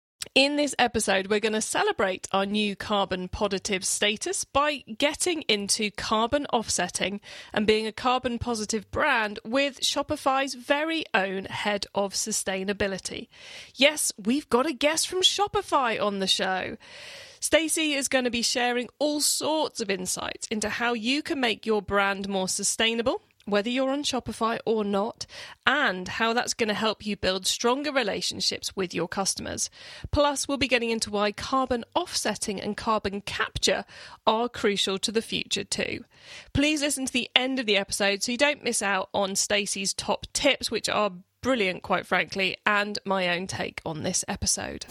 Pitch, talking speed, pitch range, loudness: 225 Hz, 165 wpm, 200-275 Hz, -26 LUFS